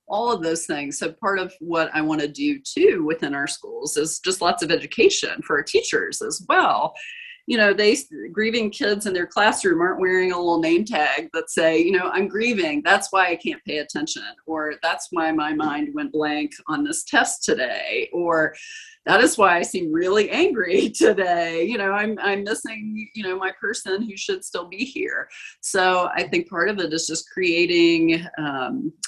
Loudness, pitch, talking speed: -21 LUFS, 210 Hz, 200 wpm